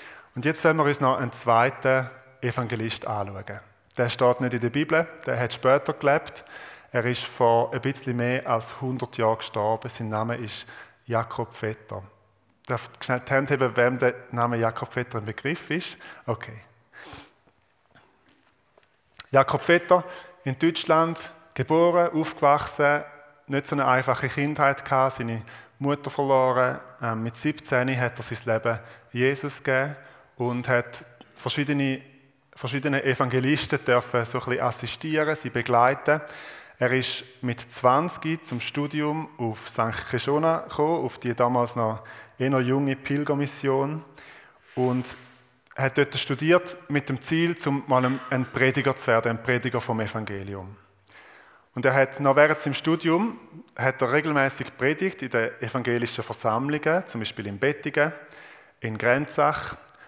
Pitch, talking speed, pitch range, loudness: 130 Hz, 135 wpm, 120-145 Hz, -25 LUFS